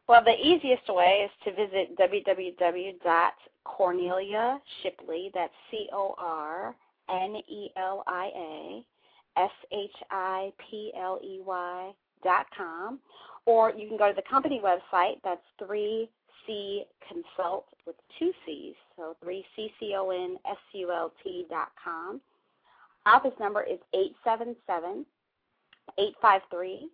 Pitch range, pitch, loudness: 185-235 Hz, 205 Hz, -29 LUFS